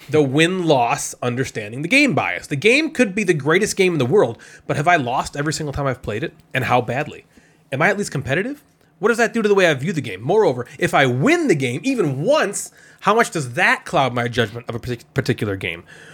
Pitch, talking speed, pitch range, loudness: 155 Hz, 240 wpm, 130-205 Hz, -19 LUFS